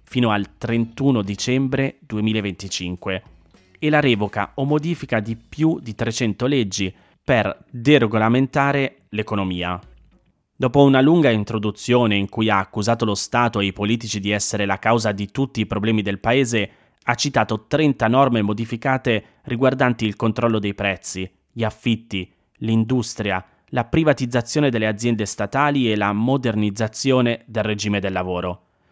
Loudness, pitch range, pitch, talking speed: -20 LUFS, 100-125 Hz, 110 Hz, 135 wpm